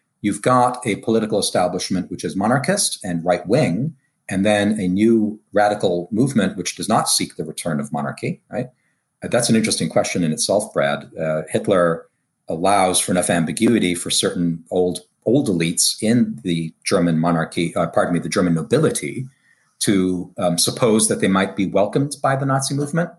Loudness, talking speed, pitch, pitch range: -19 LUFS, 170 wpm, 105 Hz, 85-125 Hz